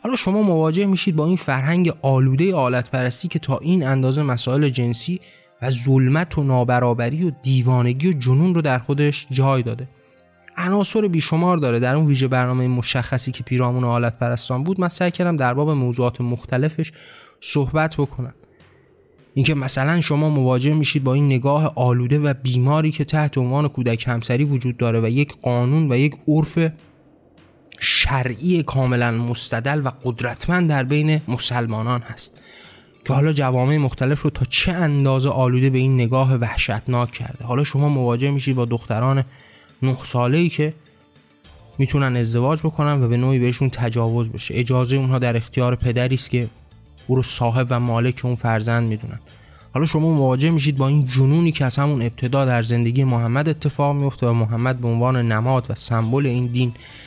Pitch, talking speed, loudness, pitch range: 130 Hz, 160 wpm, -19 LUFS, 125-150 Hz